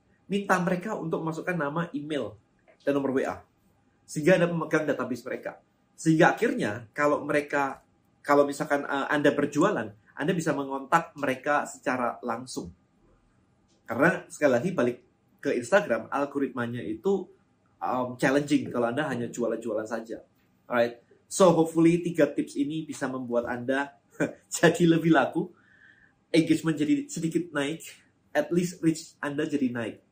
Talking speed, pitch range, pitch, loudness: 135 wpm, 135-165 Hz, 145 Hz, -27 LUFS